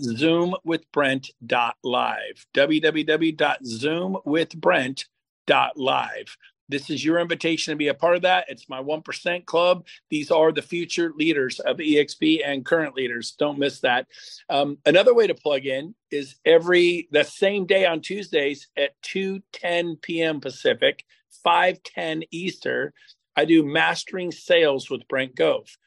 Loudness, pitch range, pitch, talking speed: -22 LUFS, 145-185 Hz, 165 Hz, 130 wpm